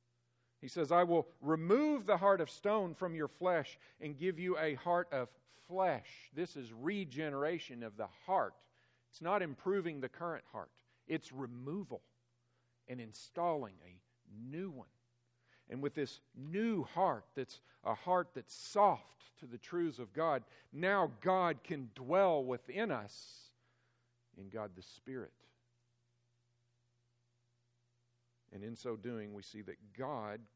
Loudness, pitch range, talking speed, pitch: -38 LUFS, 120-170 Hz, 140 wpm, 130 Hz